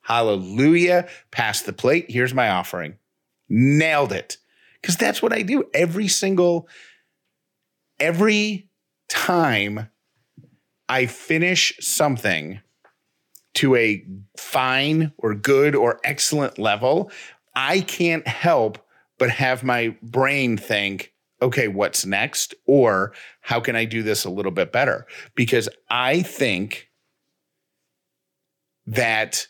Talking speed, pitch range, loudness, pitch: 110 wpm, 110-170 Hz, -20 LUFS, 130 Hz